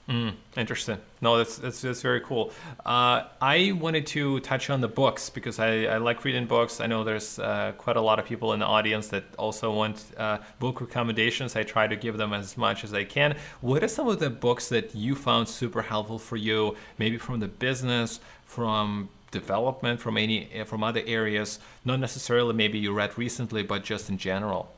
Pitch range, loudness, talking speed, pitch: 110-125 Hz, -27 LUFS, 205 wpm, 115 Hz